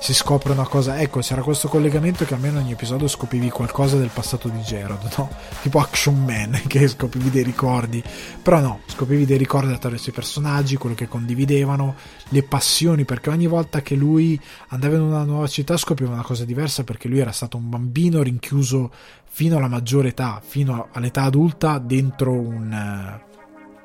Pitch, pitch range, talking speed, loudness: 135 Hz, 120-145 Hz, 175 wpm, -20 LUFS